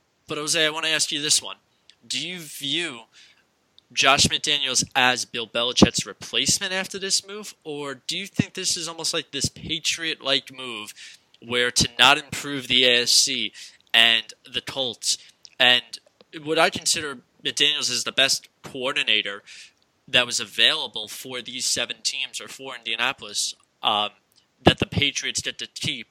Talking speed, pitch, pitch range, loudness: 155 wpm, 140 Hz, 125-160 Hz, -21 LUFS